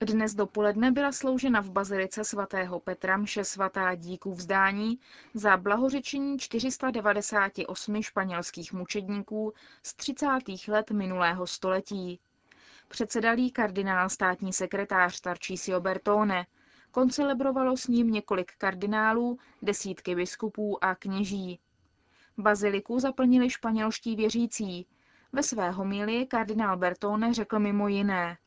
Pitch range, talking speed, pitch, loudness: 190-230 Hz, 105 wpm, 205 Hz, -29 LUFS